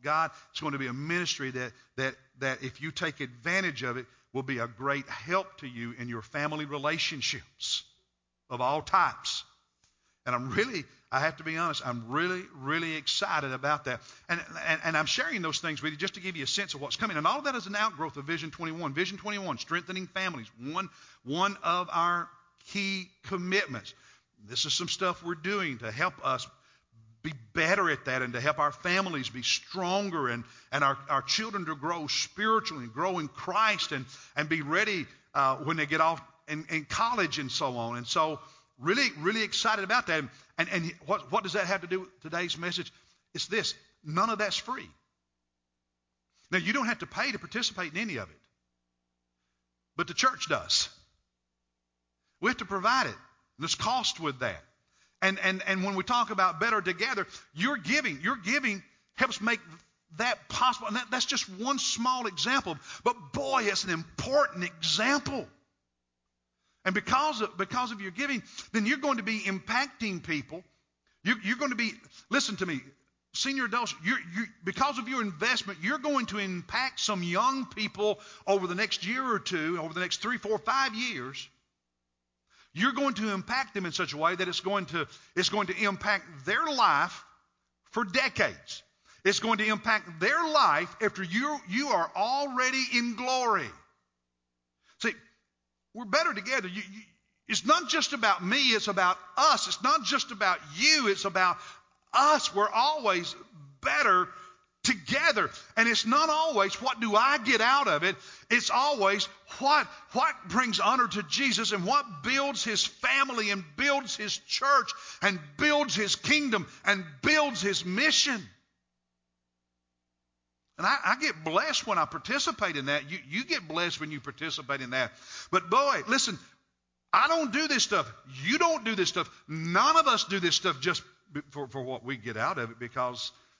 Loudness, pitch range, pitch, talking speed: -29 LUFS, 145-225 Hz, 185 Hz, 180 wpm